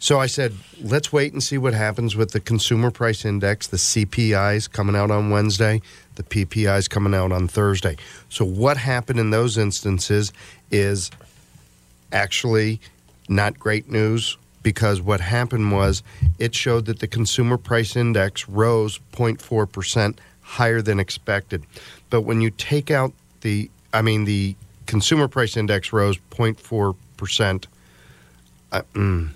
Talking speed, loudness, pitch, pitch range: 140 wpm, -21 LUFS, 105 Hz, 100-115 Hz